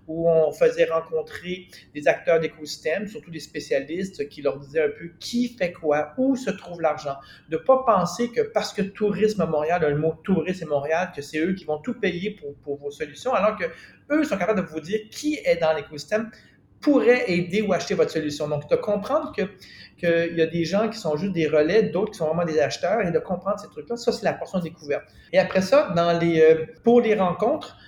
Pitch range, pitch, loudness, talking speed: 160-215 Hz, 175 Hz, -24 LUFS, 220 wpm